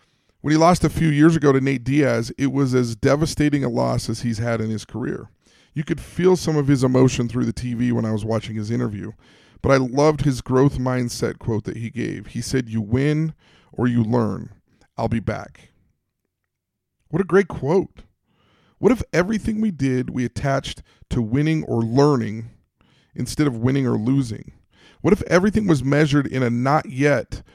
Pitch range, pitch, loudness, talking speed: 115-150 Hz, 130 Hz, -21 LUFS, 190 wpm